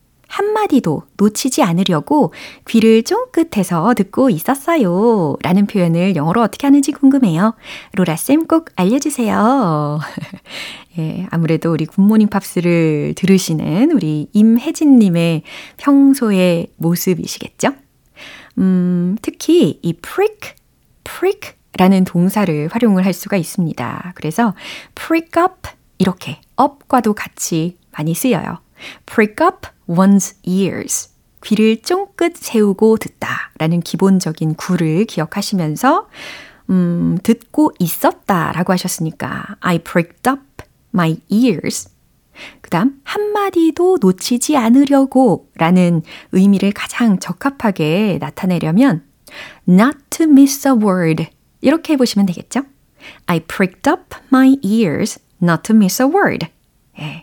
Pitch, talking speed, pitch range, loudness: 205 Hz, 300 characters per minute, 175-270 Hz, -15 LUFS